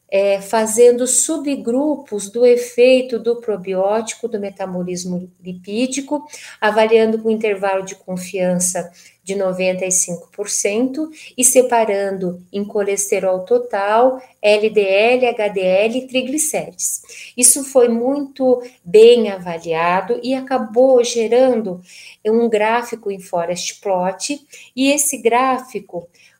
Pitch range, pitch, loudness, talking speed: 190-250 Hz, 220 Hz, -16 LUFS, 100 wpm